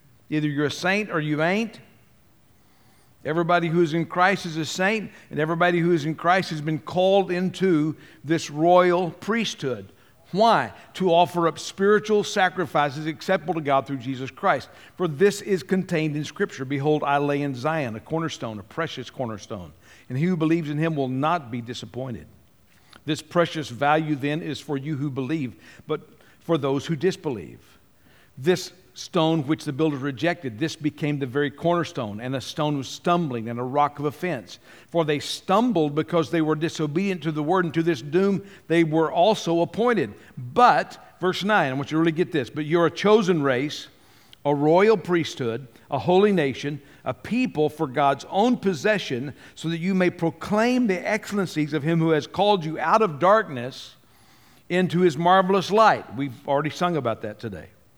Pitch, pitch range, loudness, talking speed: 160 Hz, 140-180 Hz, -23 LUFS, 180 wpm